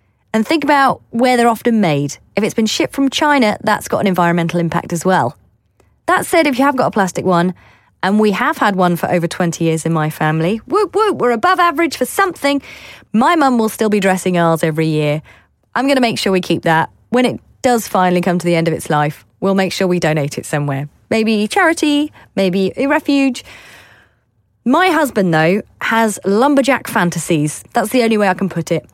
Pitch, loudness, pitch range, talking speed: 195 Hz, -15 LUFS, 165-250 Hz, 210 wpm